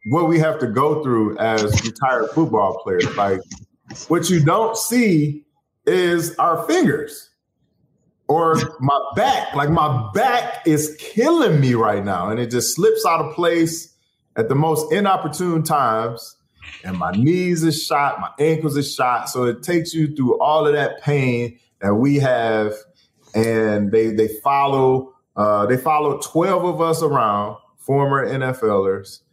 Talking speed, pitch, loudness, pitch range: 155 wpm, 140 Hz, -18 LUFS, 115-160 Hz